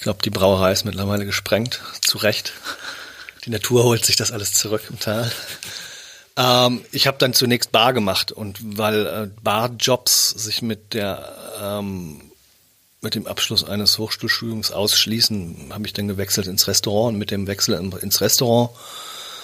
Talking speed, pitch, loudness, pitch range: 155 wpm, 110 Hz, -19 LUFS, 100-120 Hz